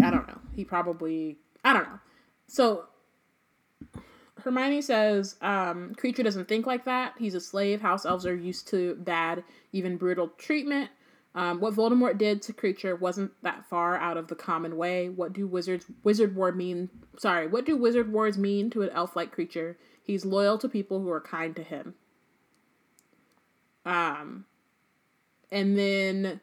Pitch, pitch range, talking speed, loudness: 195 Hz, 175-225 Hz, 165 wpm, -28 LUFS